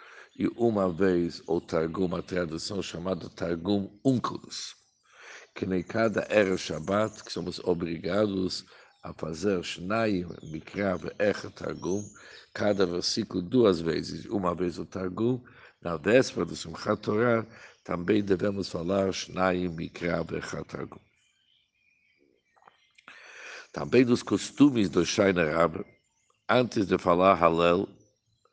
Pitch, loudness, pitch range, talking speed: 95 Hz, -28 LUFS, 90-105 Hz, 90 wpm